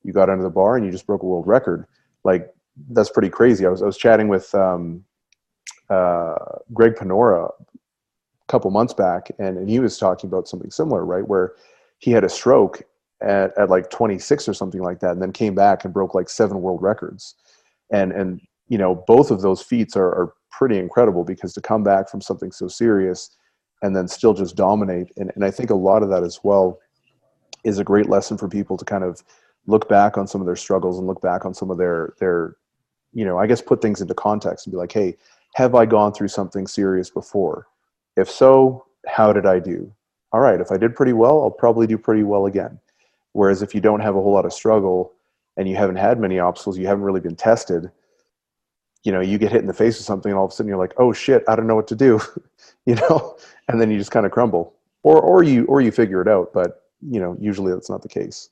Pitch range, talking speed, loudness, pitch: 95-110 Hz, 235 wpm, -18 LUFS, 100 Hz